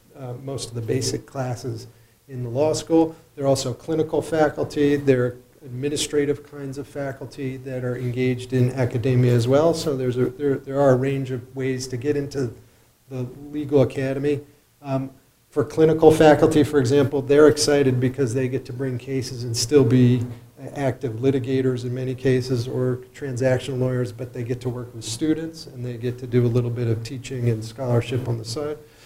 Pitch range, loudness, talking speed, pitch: 125-145 Hz, -22 LUFS, 185 wpm, 130 Hz